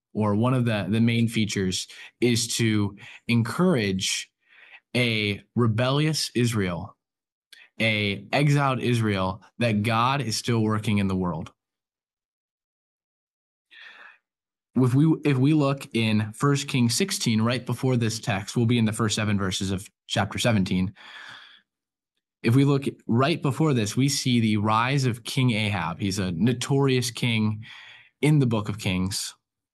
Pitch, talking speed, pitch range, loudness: 115 Hz, 140 wpm, 105-130 Hz, -24 LUFS